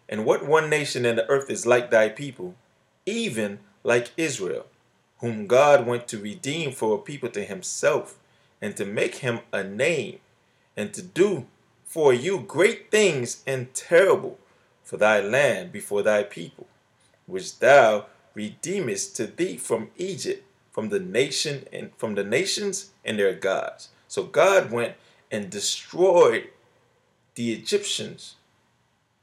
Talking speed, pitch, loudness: 140 wpm, 135 Hz, -24 LUFS